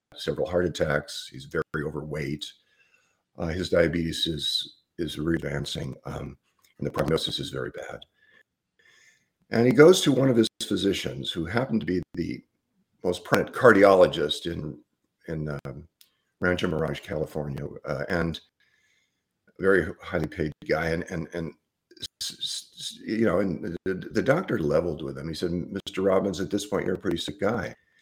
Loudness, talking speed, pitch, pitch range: -26 LUFS, 160 wpm, 90 Hz, 80-115 Hz